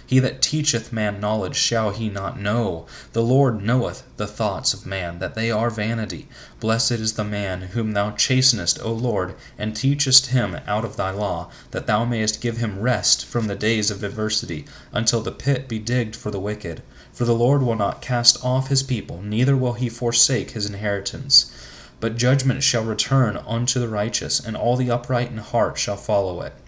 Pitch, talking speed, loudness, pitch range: 115 Hz, 195 wpm, -21 LUFS, 105-125 Hz